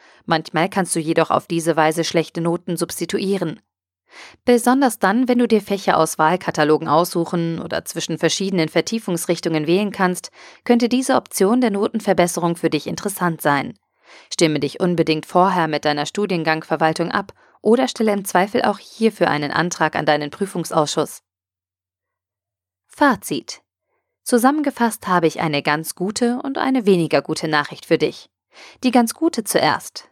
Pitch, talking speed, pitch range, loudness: 175 Hz, 140 wpm, 160-210 Hz, -19 LUFS